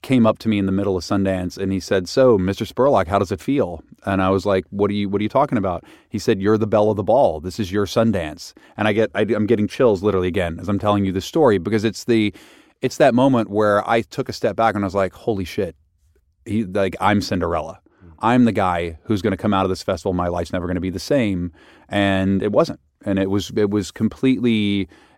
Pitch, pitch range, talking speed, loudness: 100 Hz, 95-110 Hz, 255 wpm, -20 LUFS